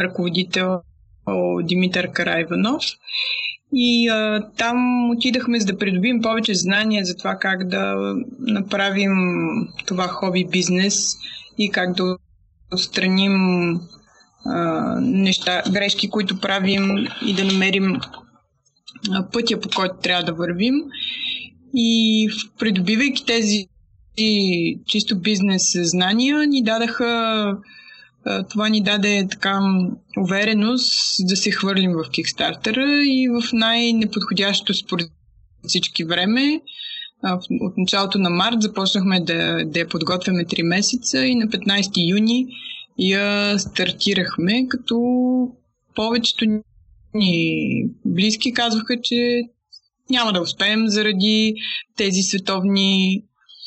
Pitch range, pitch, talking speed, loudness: 185-230 Hz, 205 Hz, 105 wpm, -19 LUFS